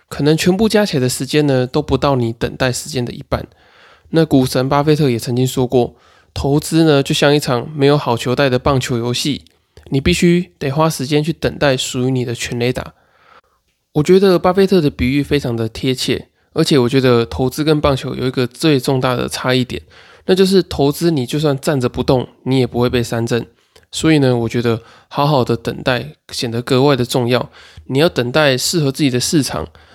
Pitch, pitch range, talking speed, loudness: 135 Hz, 125-150 Hz, 300 characters per minute, -16 LUFS